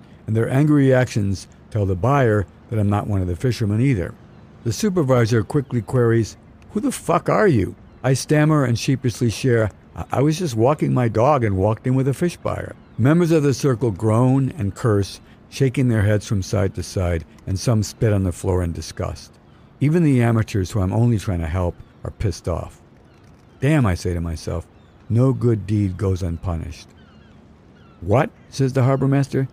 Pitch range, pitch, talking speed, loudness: 95-130 Hz, 110 Hz, 185 wpm, -20 LUFS